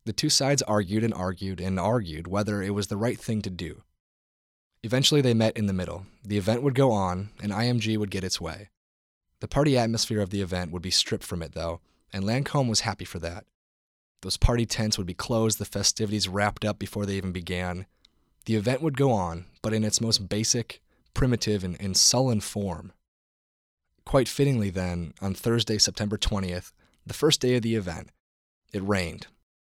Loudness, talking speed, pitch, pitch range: -26 LUFS, 190 wpm, 105 Hz, 90-115 Hz